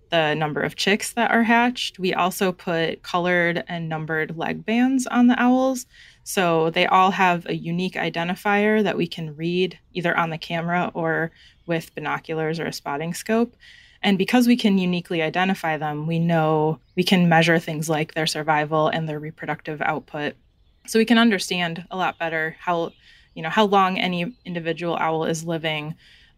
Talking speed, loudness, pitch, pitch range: 175 wpm, -22 LUFS, 175 Hz, 160-195 Hz